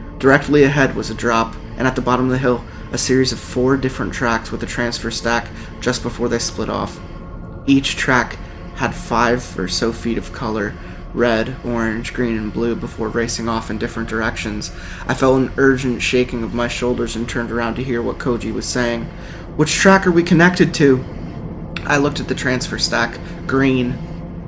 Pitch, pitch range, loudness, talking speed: 120 Hz, 110-130 Hz, -18 LUFS, 190 wpm